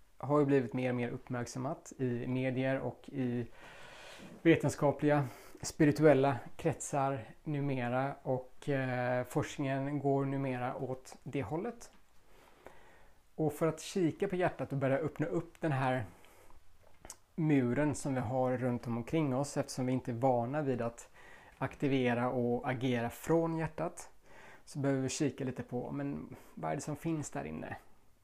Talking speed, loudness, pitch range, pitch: 145 wpm, -34 LUFS, 125-150 Hz, 135 Hz